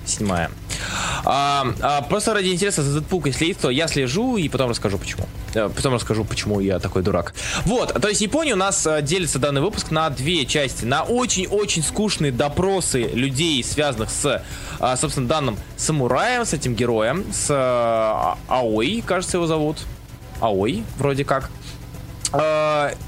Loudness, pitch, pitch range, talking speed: -21 LUFS, 140 Hz, 115-165 Hz, 155 wpm